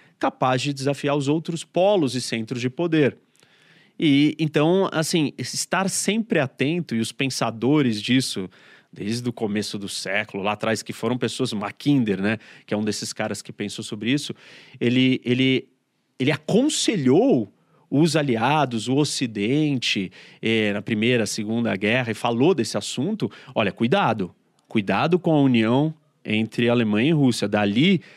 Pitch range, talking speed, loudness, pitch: 110-150 Hz, 145 wpm, -22 LUFS, 130 Hz